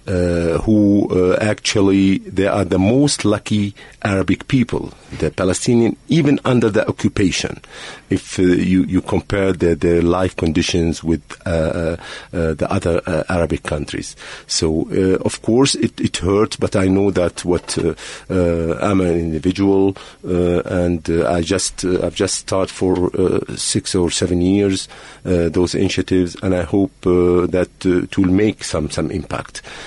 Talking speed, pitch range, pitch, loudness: 165 wpm, 85-100 Hz, 90 Hz, -17 LUFS